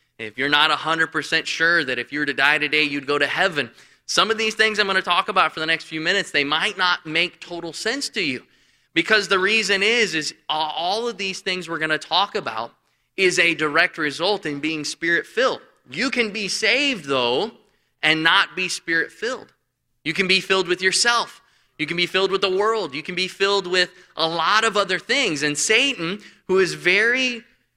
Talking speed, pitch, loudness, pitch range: 210 wpm, 175 Hz, -20 LUFS, 155-195 Hz